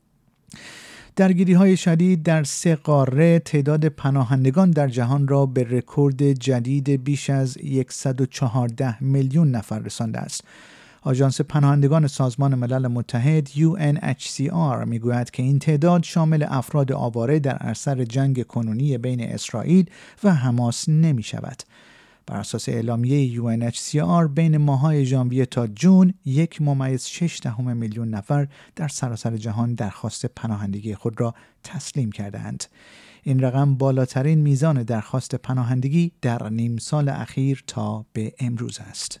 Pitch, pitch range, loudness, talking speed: 135 Hz, 120-150 Hz, -21 LUFS, 120 wpm